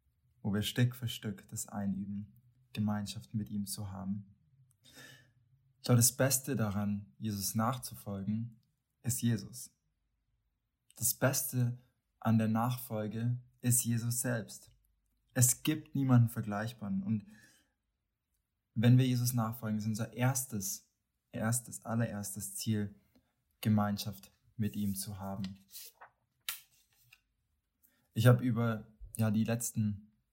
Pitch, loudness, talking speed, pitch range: 110 Hz, -34 LUFS, 105 wpm, 105-125 Hz